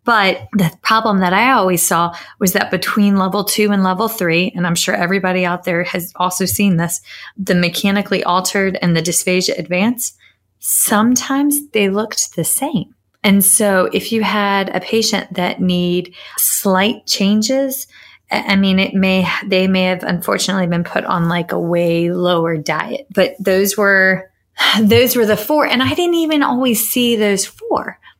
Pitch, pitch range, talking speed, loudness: 195 Hz, 180-215 Hz, 170 wpm, -15 LUFS